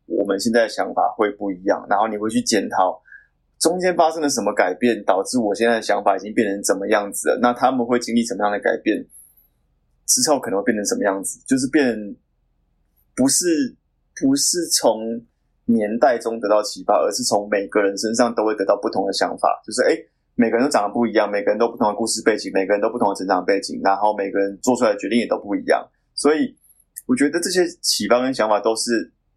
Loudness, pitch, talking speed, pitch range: -20 LUFS, 110 Hz, 335 characters per minute, 100-125 Hz